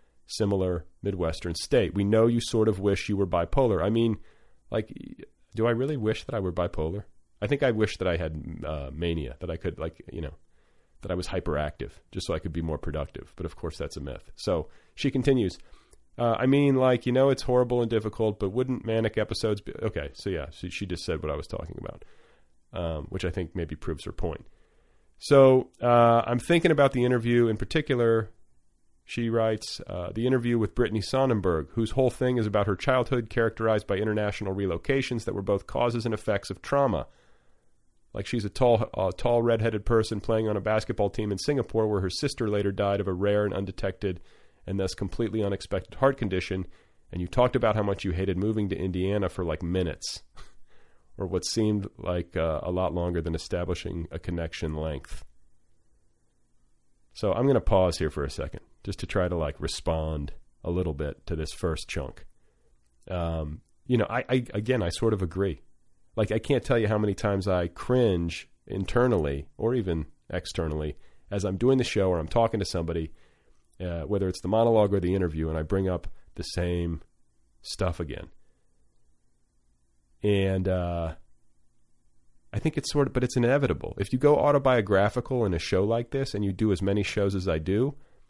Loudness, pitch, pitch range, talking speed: -27 LUFS, 100 Hz, 85-115 Hz, 195 wpm